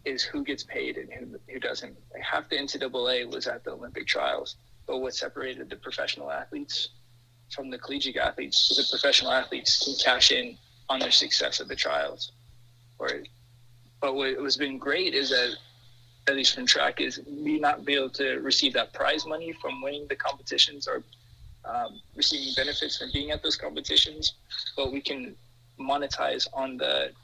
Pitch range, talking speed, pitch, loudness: 120-140 Hz, 175 wpm, 130 Hz, -26 LUFS